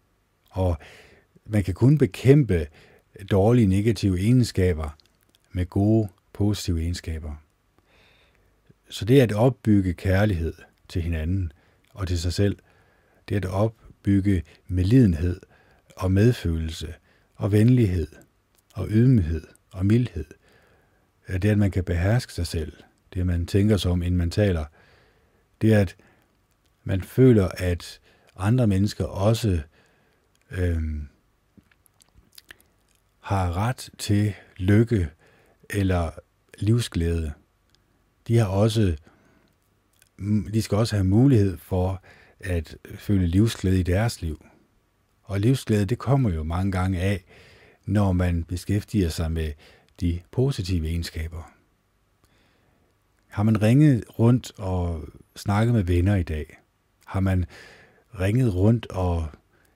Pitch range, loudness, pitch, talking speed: 90-105 Hz, -23 LUFS, 95 Hz, 110 wpm